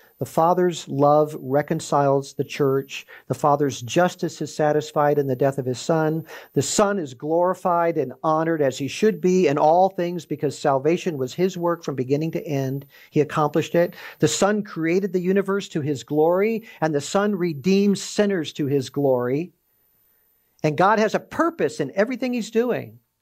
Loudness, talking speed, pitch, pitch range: -22 LUFS, 175 wpm, 160 Hz, 145-185 Hz